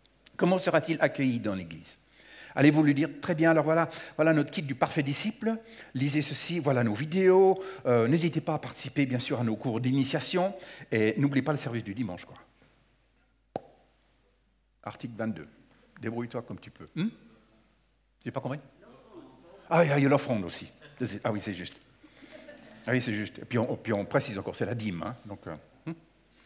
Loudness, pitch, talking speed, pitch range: -28 LUFS, 145 Hz, 175 wpm, 120-165 Hz